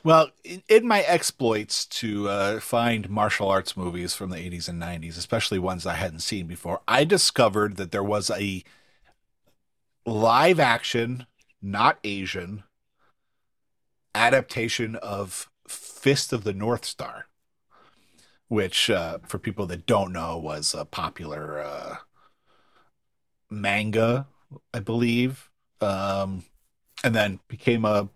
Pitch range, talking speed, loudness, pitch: 95-120 Hz, 120 wpm, -25 LUFS, 105 Hz